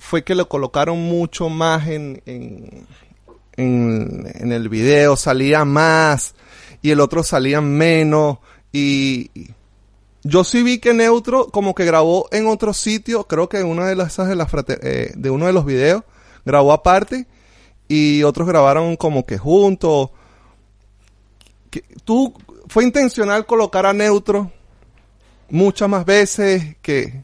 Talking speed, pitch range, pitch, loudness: 145 wpm, 125-190 Hz, 155 Hz, -16 LUFS